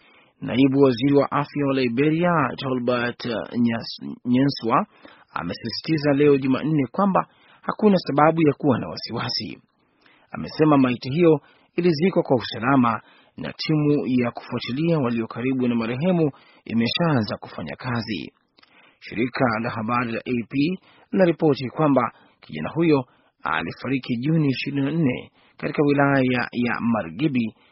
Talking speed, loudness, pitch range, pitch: 110 wpm, -22 LUFS, 120-155 Hz, 135 Hz